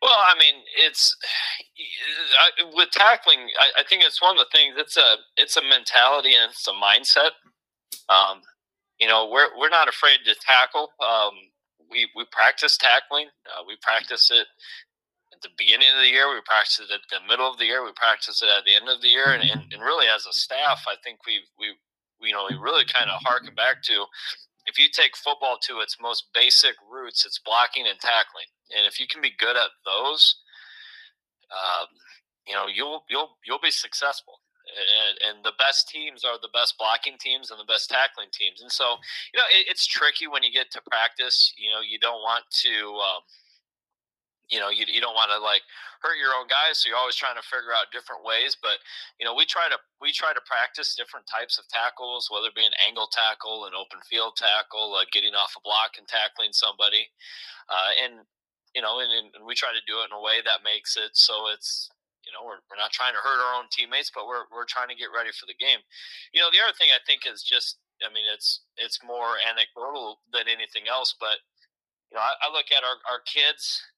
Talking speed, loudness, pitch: 220 wpm, -20 LUFS, 145 Hz